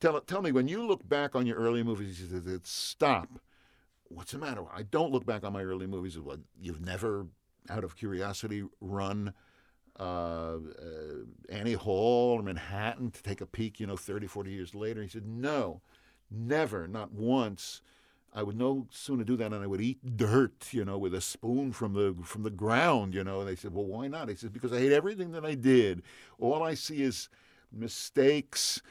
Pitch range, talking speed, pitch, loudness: 95-130 Hz, 205 wpm, 110 Hz, -32 LUFS